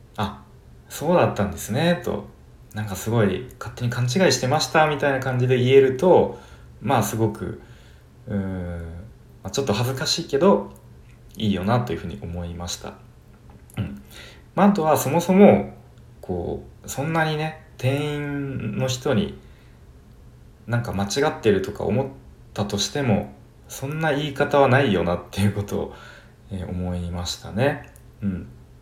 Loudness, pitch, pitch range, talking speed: -22 LUFS, 115 Hz, 95-140 Hz, 285 characters per minute